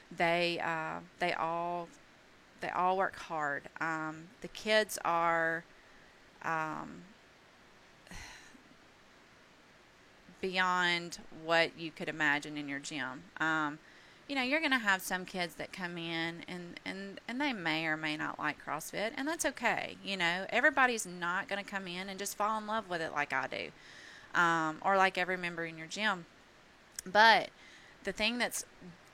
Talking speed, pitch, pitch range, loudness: 155 wpm, 175 Hz, 160-200 Hz, -33 LUFS